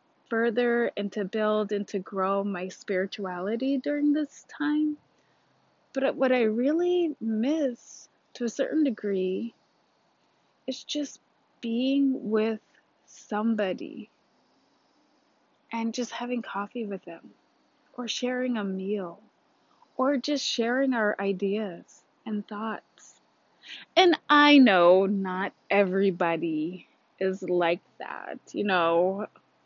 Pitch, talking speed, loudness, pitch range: 225 Hz, 105 wpm, -27 LUFS, 195-270 Hz